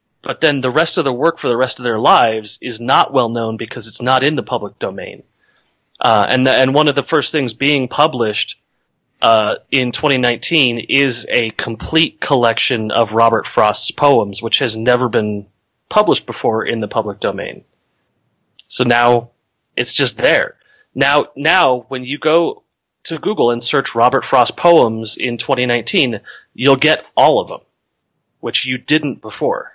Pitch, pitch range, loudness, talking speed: 125 Hz, 115-140 Hz, -15 LUFS, 175 wpm